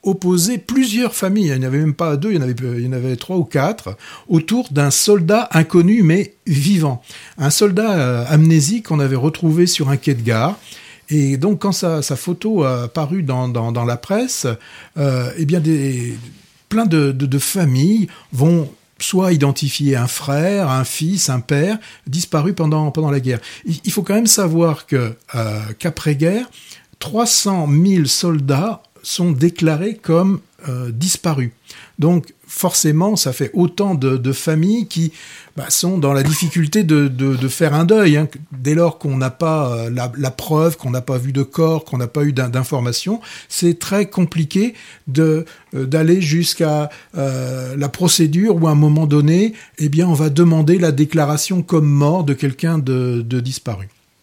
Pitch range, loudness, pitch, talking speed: 135-180 Hz, -16 LUFS, 155 Hz, 180 wpm